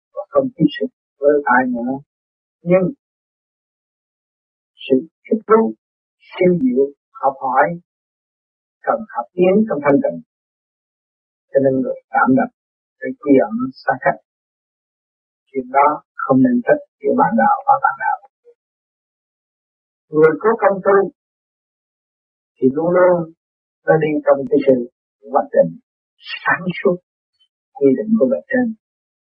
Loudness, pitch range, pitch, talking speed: -17 LUFS, 140-230 Hz, 180 Hz, 125 wpm